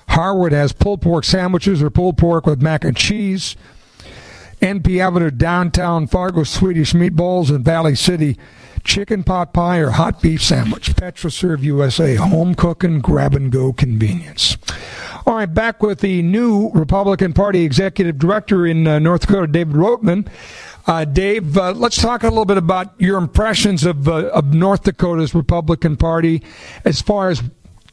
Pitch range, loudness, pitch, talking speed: 155-190 Hz, -15 LUFS, 175 Hz, 150 wpm